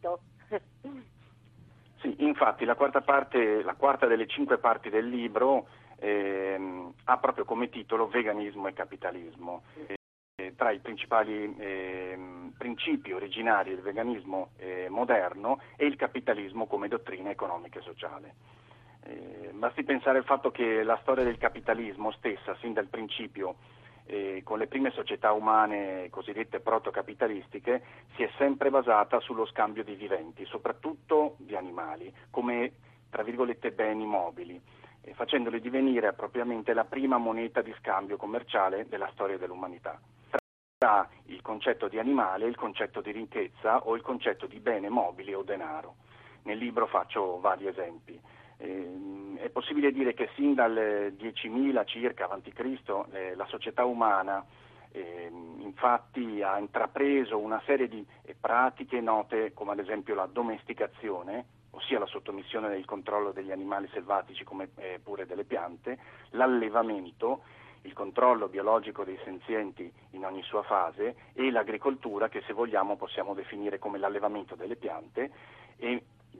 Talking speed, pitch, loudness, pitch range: 135 wpm, 115 Hz, -31 LUFS, 100-125 Hz